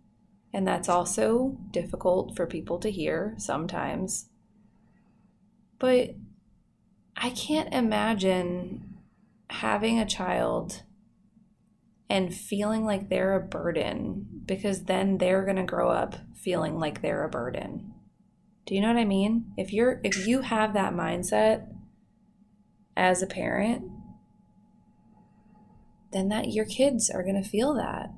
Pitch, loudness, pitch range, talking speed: 210 Hz, -28 LUFS, 190-220 Hz, 125 wpm